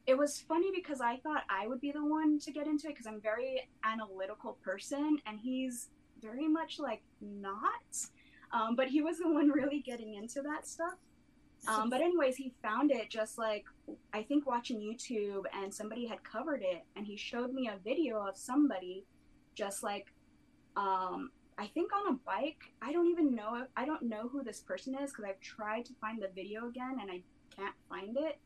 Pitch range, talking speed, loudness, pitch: 215-295 Hz, 200 wpm, -37 LUFS, 255 Hz